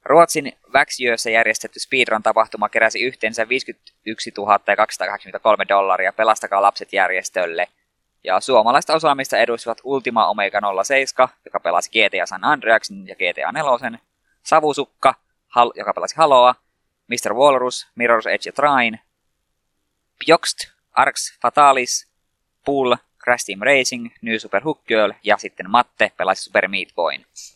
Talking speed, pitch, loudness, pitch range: 125 wpm, 115 Hz, -18 LUFS, 110-135 Hz